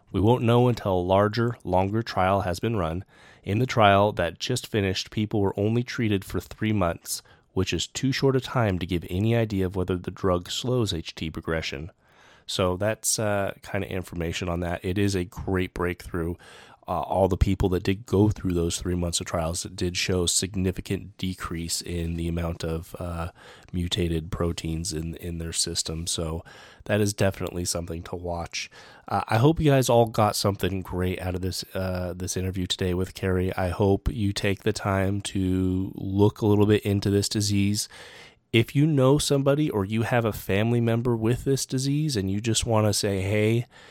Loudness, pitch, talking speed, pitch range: -25 LUFS, 95 Hz, 195 wpm, 90-110 Hz